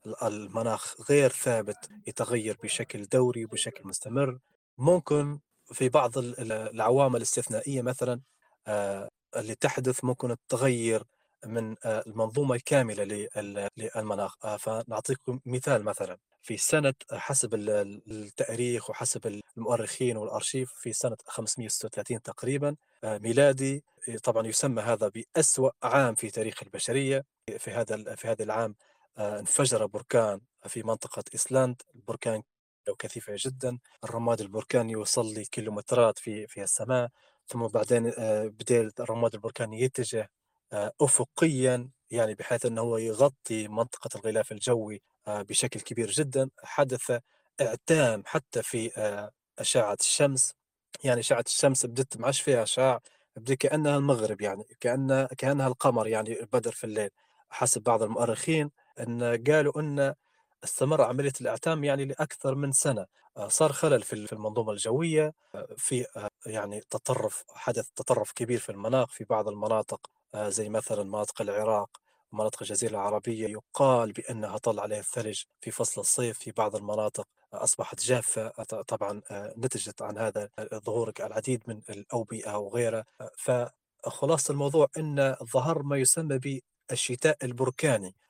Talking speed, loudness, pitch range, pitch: 115 wpm, -29 LUFS, 110-135 Hz, 120 Hz